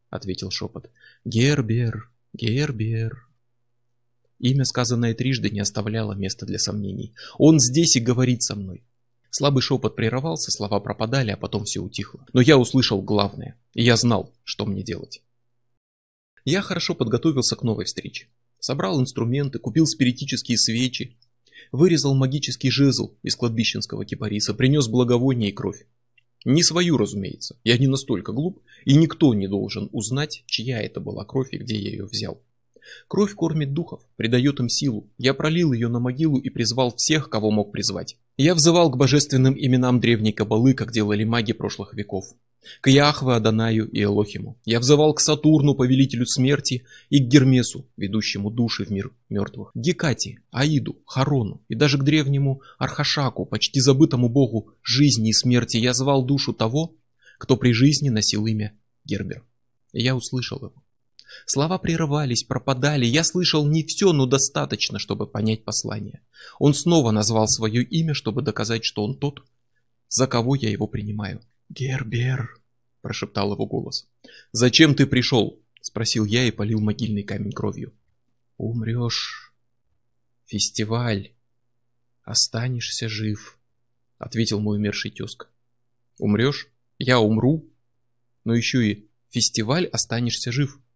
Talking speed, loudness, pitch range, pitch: 140 wpm, -21 LUFS, 110-135 Hz, 120 Hz